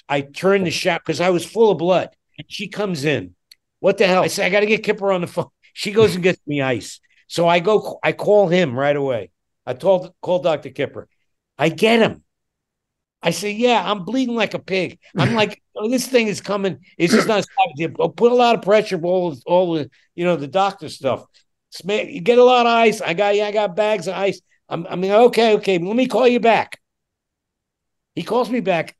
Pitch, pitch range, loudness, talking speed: 195 Hz, 170-215 Hz, -18 LUFS, 235 wpm